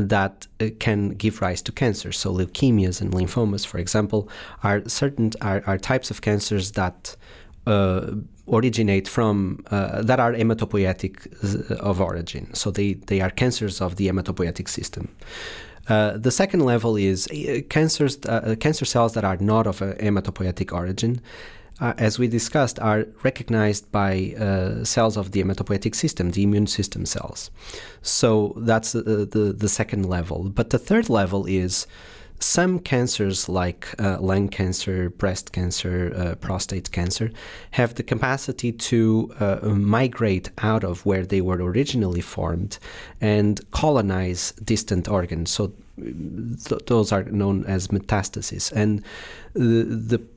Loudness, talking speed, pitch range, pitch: -23 LUFS, 145 wpm, 95-115 Hz, 105 Hz